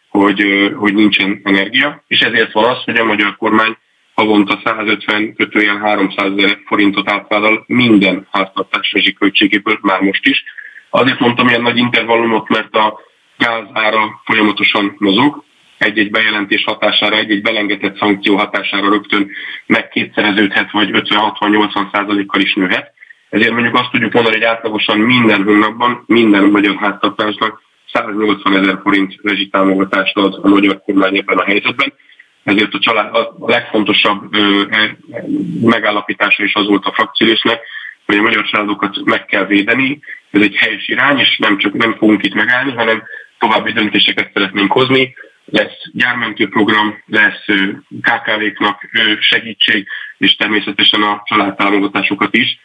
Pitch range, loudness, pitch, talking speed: 100-110 Hz, -12 LUFS, 105 Hz, 130 wpm